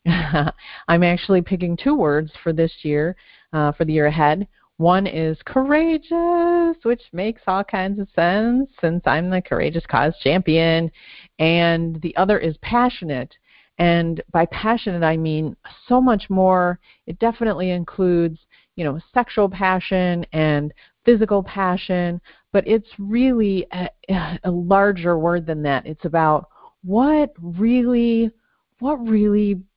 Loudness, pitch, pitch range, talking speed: -20 LUFS, 180 Hz, 165-215 Hz, 135 wpm